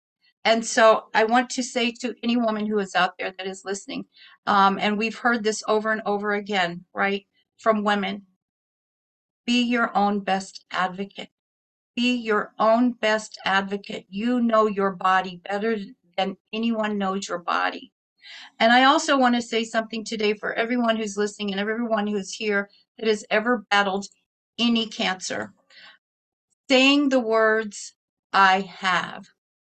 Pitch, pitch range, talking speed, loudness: 215 Hz, 195-230 Hz, 150 wpm, -23 LUFS